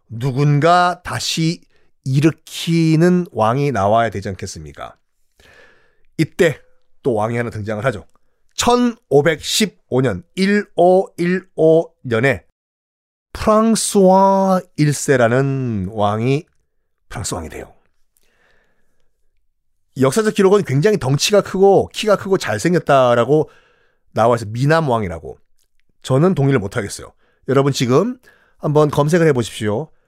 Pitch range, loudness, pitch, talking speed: 115-180 Hz, -16 LUFS, 145 Hz, 220 characters per minute